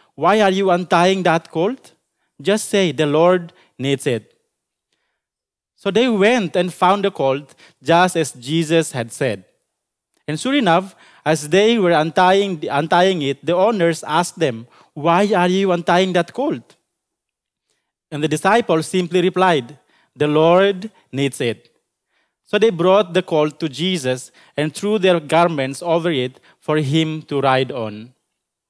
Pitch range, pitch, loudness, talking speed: 150-185 Hz, 170 Hz, -17 LUFS, 145 wpm